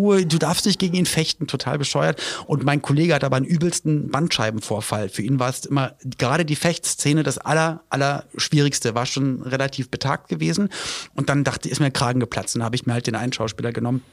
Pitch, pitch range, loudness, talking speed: 140 Hz, 125-160 Hz, -22 LUFS, 215 wpm